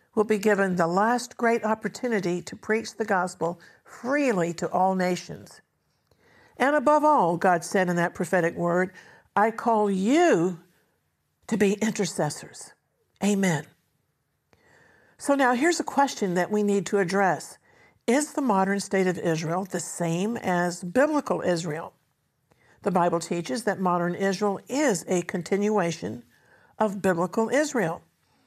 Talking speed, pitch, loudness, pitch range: 135 wpm, 195 Hz, -25 LUFS, 175-225 Hz